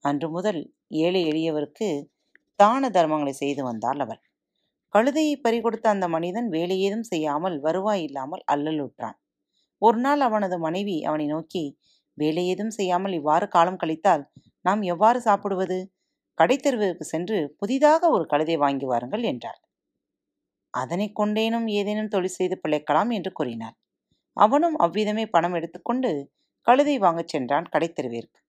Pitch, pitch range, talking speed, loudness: 180 Hz, 155-215 Hz, 120 wpm, -24 LUFS